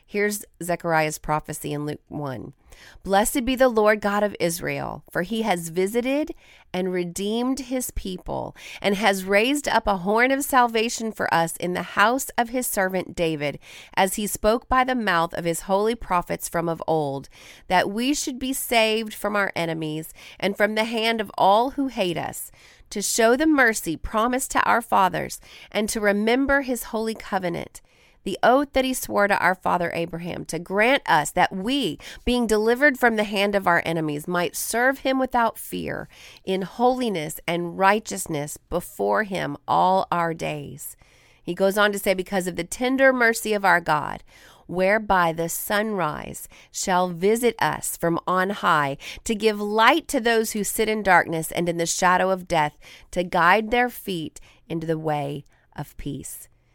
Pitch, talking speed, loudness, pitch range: 200 Hz, 175 wpm, -23 LUFS, 170-230 Hz